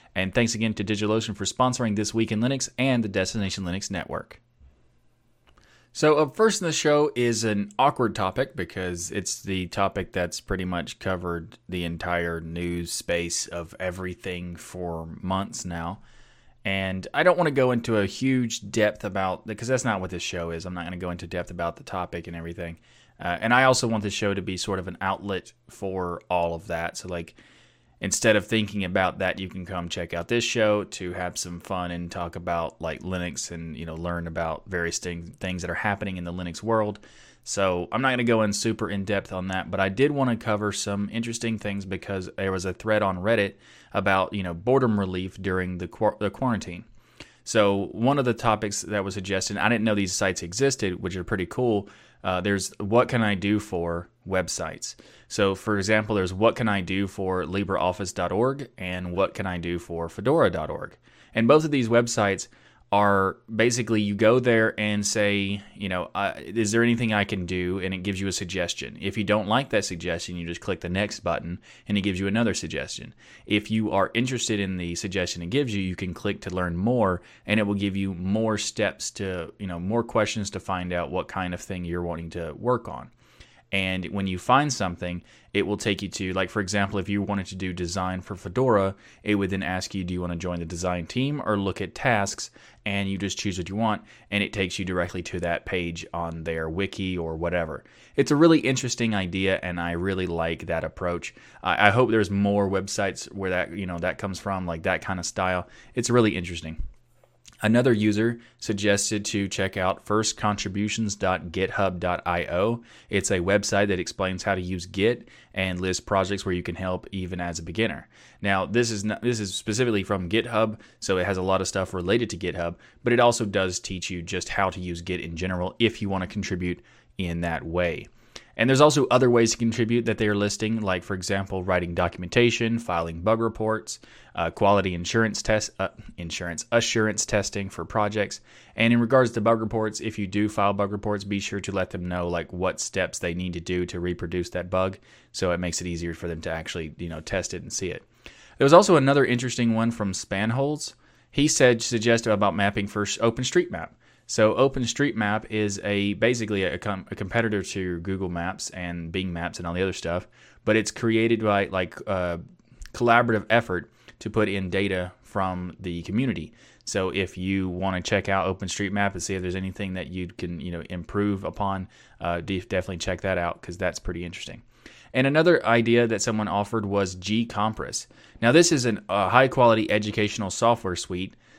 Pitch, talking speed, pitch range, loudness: 100 Hz, 205 wpm, 90-110 Hz, -25 LUFS